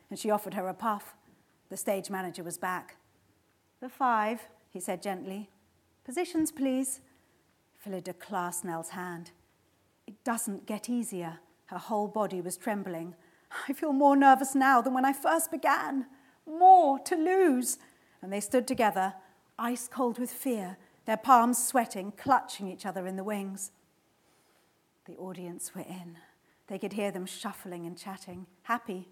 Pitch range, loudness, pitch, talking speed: 185-255 Hz, -29 LUFS, 205 Hz, 150 wpm